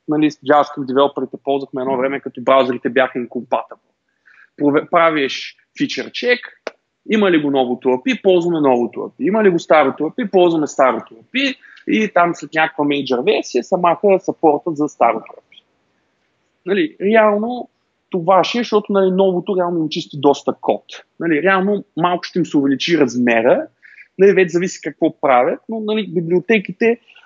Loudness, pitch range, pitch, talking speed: -16 LUFS, 140-195 Hz, 170 Hz, 150 wpm